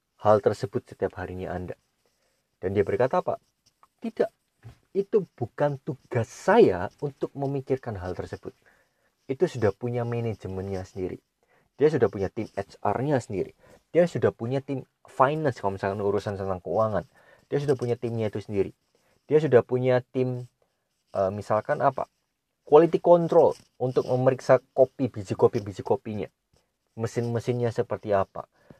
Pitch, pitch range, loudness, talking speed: 120 Hz, 100-135 Hz, -26 LUFS, 135 wpm